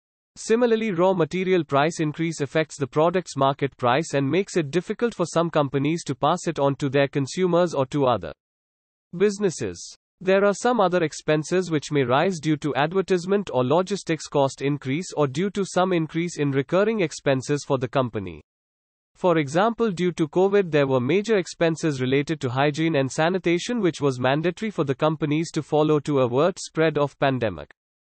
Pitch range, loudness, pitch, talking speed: 140-180 Hz, -23 LUFS, 155 Hz, 175 wpm